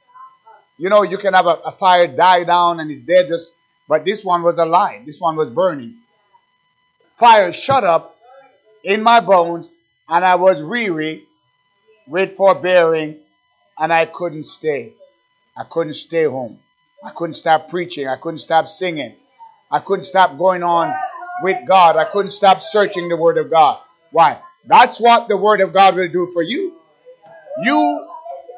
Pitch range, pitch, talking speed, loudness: 165-240 Hz, 185 Hz, 165 wpm, -15 LUFS